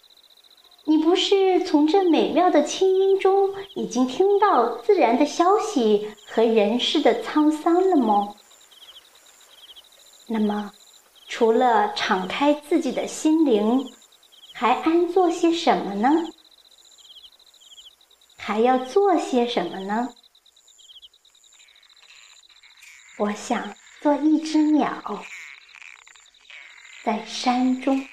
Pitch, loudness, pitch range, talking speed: 295 Hz, -21 LUFS, 235-355 Hz, 130 characters per minute